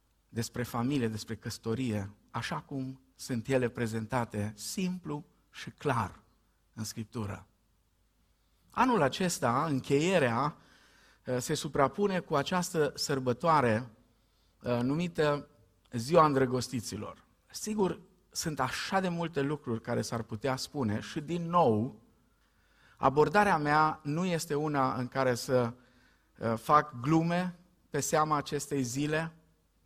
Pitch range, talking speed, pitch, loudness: 115-155 Hz, 105 wpm, 130 Hz, -31 LUFS